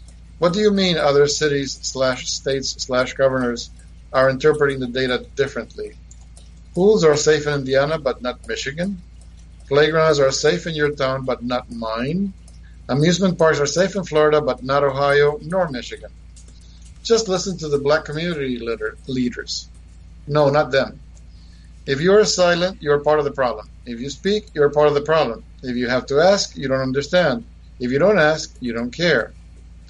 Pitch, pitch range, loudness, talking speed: 140 Hz, 120-155 Hz, -19 LUFS, 175 wpm